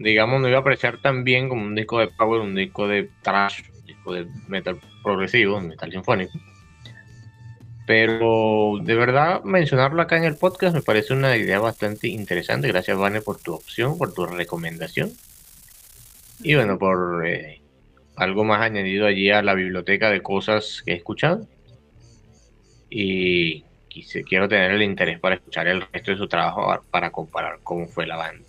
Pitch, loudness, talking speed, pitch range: 105 Hz, -21 LUFS, 165 wpm, 95-115 Hz